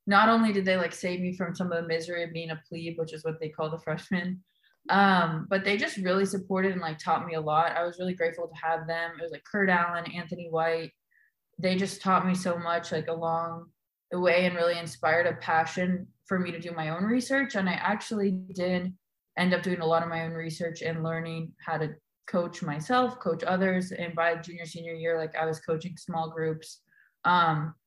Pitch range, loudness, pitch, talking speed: 165-185 Hz, -29 LUFS, 170 Hz, 225 wpm